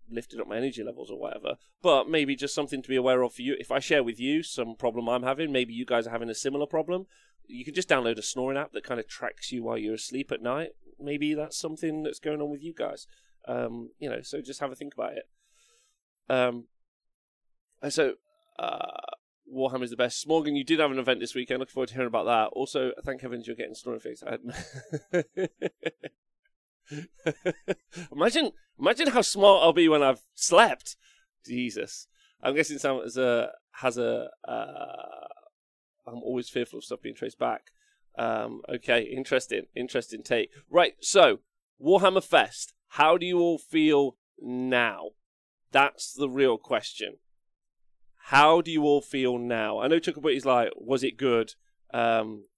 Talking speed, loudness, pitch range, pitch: 180 wpm, -27 LUFS, 125-180 Hz, 145 Hz